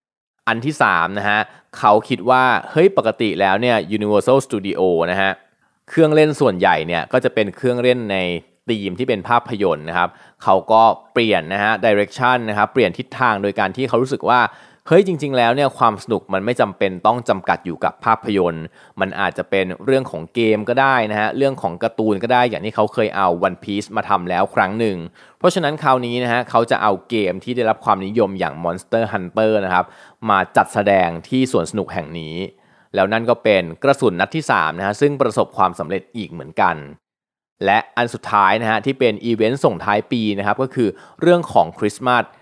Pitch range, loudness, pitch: 100-125 Hz, -18 LUFS, 110 Hz